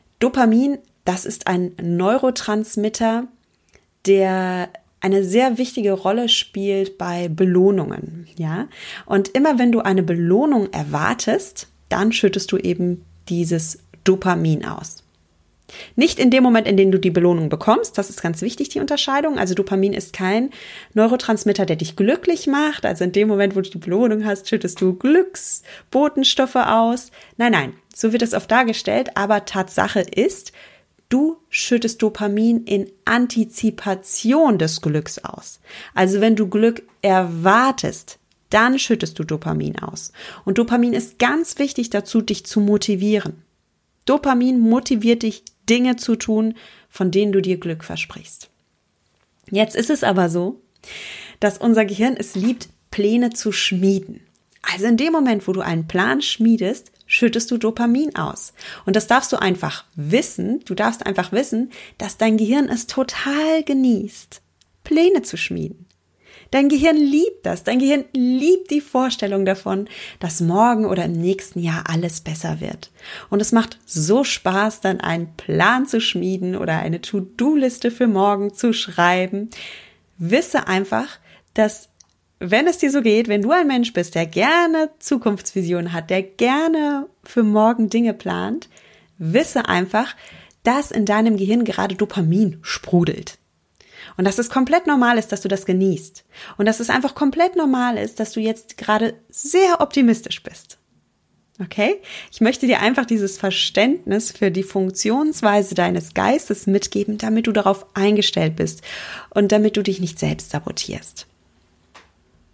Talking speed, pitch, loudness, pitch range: 150 wpm, 210 Hz, -19 LUFS, 190-245 Hz